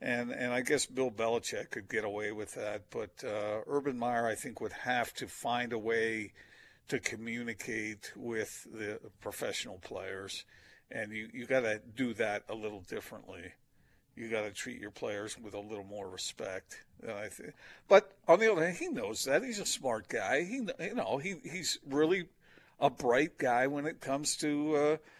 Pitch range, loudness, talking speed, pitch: 110-145 Hz, -34 LUFS, 180 wpm, 120 Hz